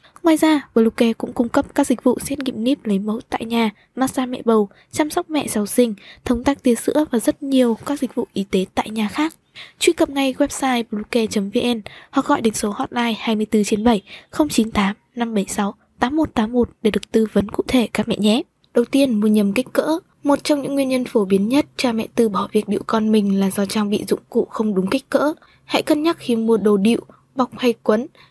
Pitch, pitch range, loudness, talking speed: 240 Hz, 215-275 Hz, -19 LUFS, 225 wpm